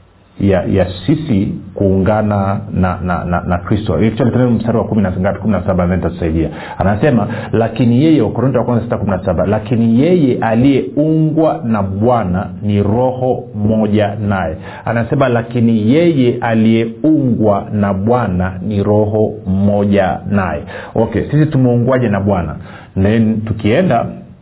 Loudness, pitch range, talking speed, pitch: -14 LUFS, 95-120 Hz, 115 wpm, 110 Hz